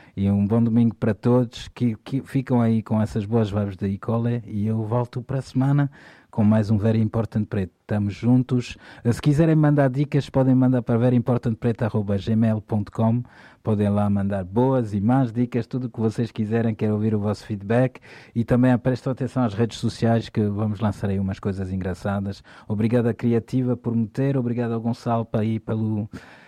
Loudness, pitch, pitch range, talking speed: -23 LUFS, 115 Hz, 105-125 Hz, 180 wpm